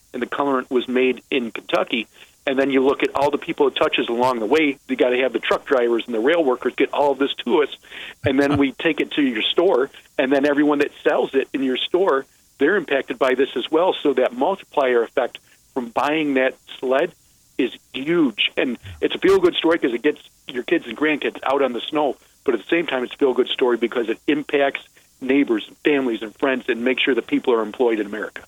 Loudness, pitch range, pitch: -20 LUFS, 130-180 Hz, 140 Hz